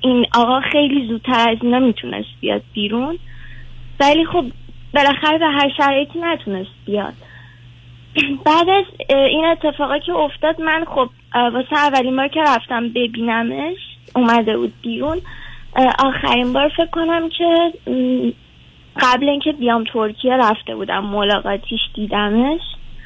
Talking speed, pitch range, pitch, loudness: 120 wpm, 210-300 Hz, 250 Hz, -17 LUFS